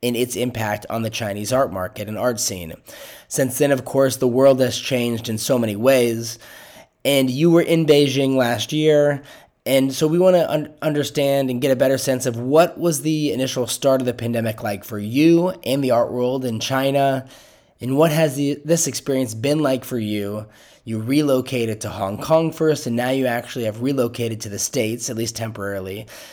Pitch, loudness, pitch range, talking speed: 130 Hz, -20 LUFS, 115-140 Hz, 200 wpm